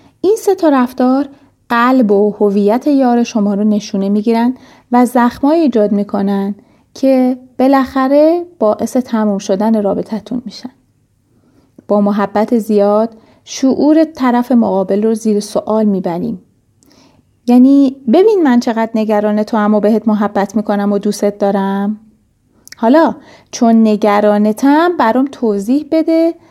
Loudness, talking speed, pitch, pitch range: -12 LUFS, 120 wpm, 225 Hz, 205-260 Hz